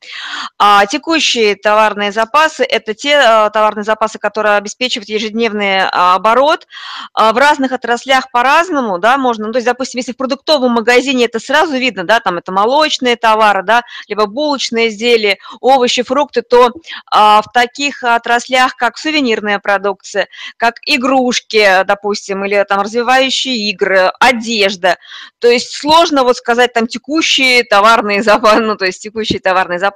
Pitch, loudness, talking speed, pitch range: 235 Hz, -11 LUFS, 140 wpm, 210-255 Hz